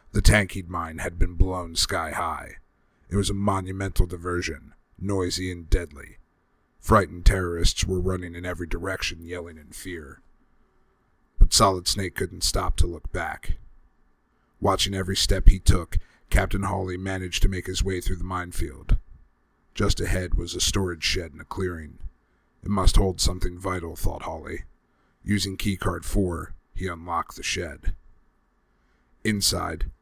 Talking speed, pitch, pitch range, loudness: 145 wpm, 90 Hz, 85-95 Hz, -26 LUFS